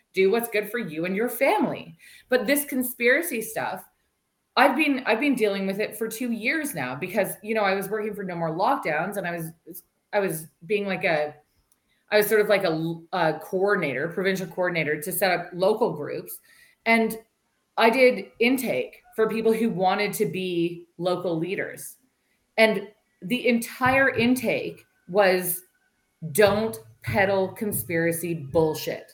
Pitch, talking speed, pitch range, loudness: 205 Hz, 150 wpm, 175-230 Hz, -24 LUFS